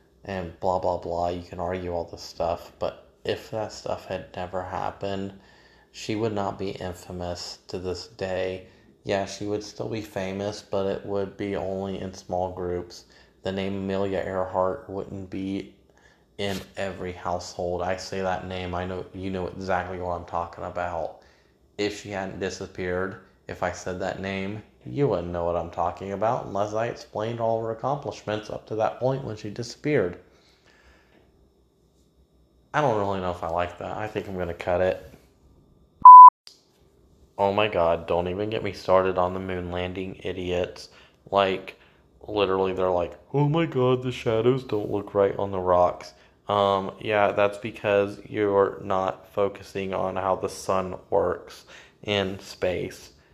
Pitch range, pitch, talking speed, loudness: 90-100 Hz, 95 Hz, 165 wpm, -24 LUFS